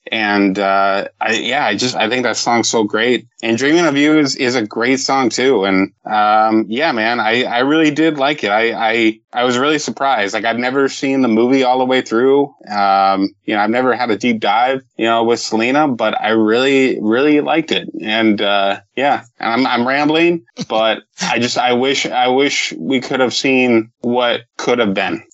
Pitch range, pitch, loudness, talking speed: 110-135 Hz, 120 Hz, -15 LUFS, 210 wpm